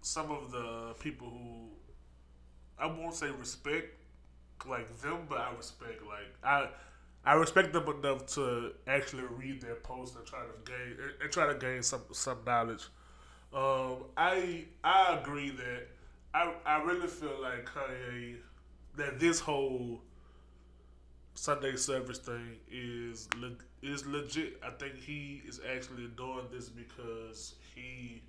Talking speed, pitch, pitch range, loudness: 140 wpm, 125 Hz, 115-140 Hz, -35 LUFS